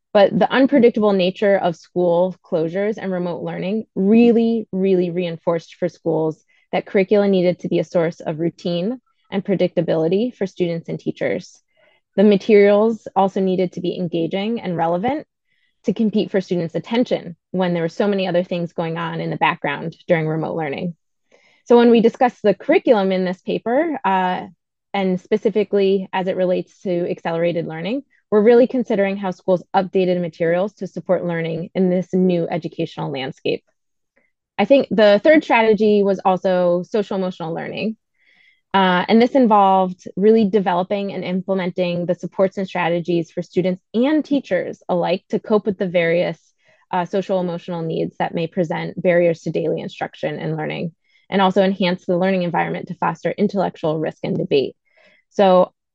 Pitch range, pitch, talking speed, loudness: 175-210 Hz, 190 Hz, 160 wpm, -19 LUFS